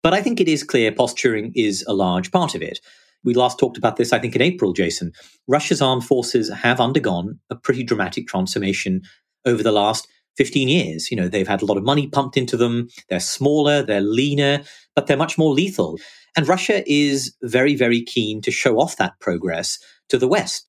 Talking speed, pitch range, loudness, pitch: 205 wpm, 105-145 Hz, -19 LUFS, 130 Hz